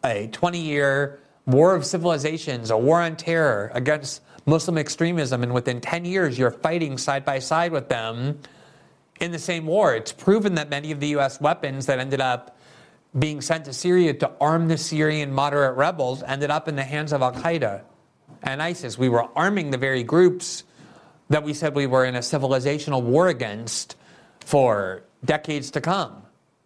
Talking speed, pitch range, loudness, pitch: 175 wpm, 135-165 Hz, -23 LUFS, 150 Hz